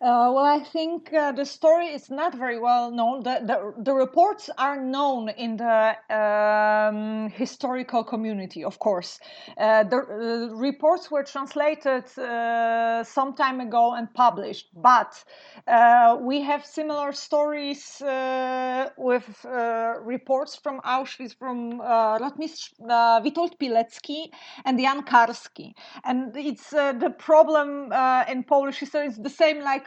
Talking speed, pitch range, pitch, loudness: 140 wpm, 235-290 Hz, 260 Hz, -23 LUFS